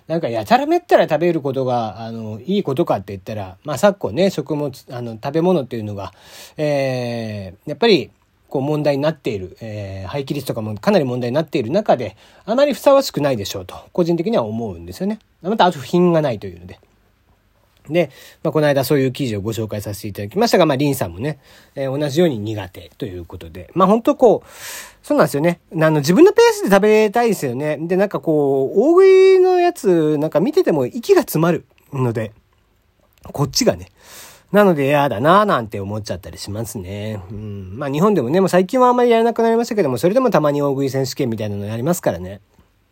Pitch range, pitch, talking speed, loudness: 110-180 Hz, 140 Hz, 435 characters per minute, -17 LUFS